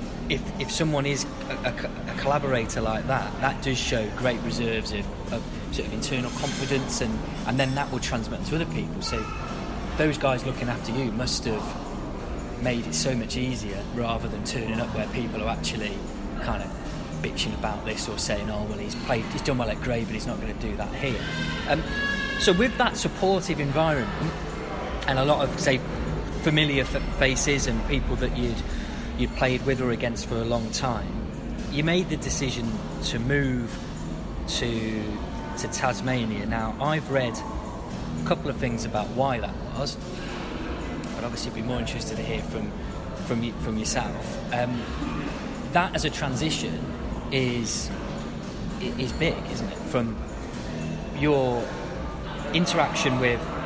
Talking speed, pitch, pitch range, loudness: 165 wpm, 125 Hz, 110-140 Hz, -27 LUFS